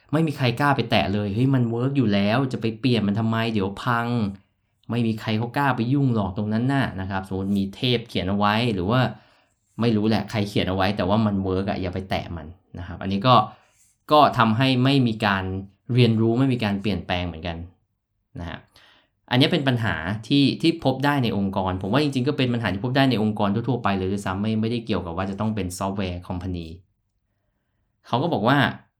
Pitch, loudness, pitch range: 105 Hz, -23 LUFS, 95-120 Hz